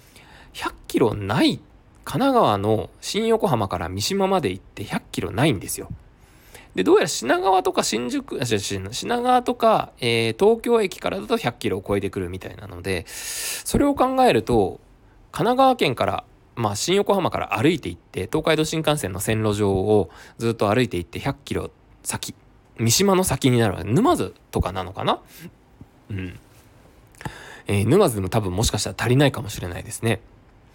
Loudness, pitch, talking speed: -22 LUFS, 120 Hz, 295 characters per minute